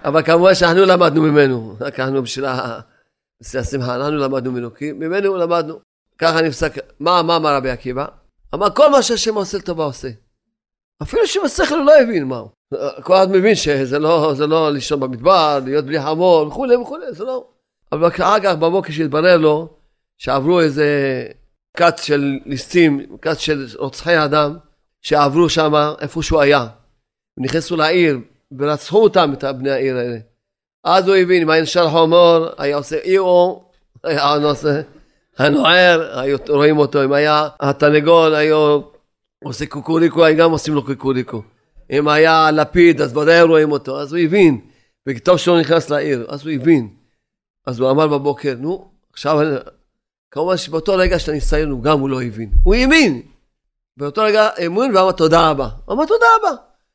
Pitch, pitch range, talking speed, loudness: 155 Hz, 140-170 Hz, 160 wpm, -15 LUFS